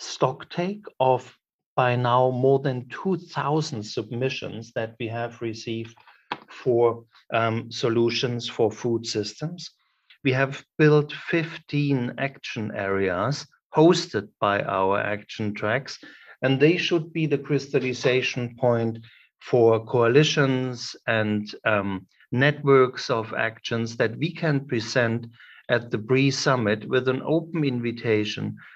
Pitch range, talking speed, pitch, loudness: 115-140 Hz, 115 wpm, 125 Hz, -24 LUFS